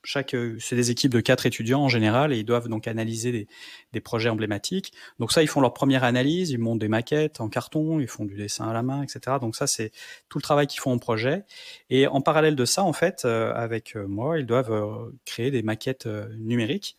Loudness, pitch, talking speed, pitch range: -25 LUFS, 125 Hz, 225 wpm, 115-140 Hz